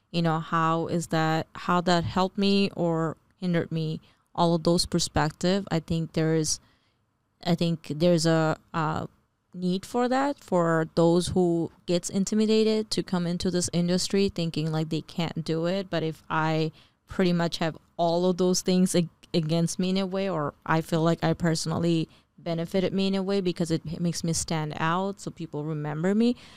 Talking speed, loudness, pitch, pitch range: 180 wpm, -26 LUFS, 170 Hz, 160-185 Hz